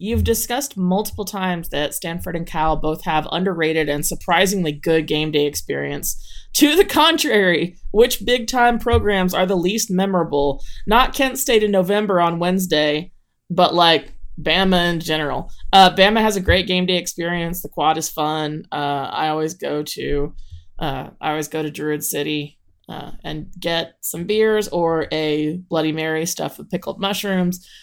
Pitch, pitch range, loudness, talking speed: 170 Hz, 155-195 Hz, -19 LUFS, 165 wpm